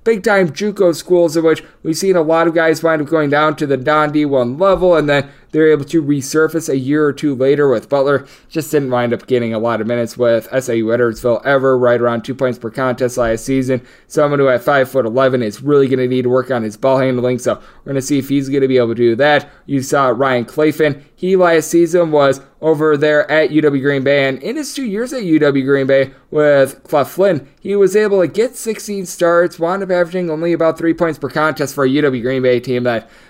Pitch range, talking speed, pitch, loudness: 130-165 Hz, 240 wpm, 145 Hz, -14 LUFS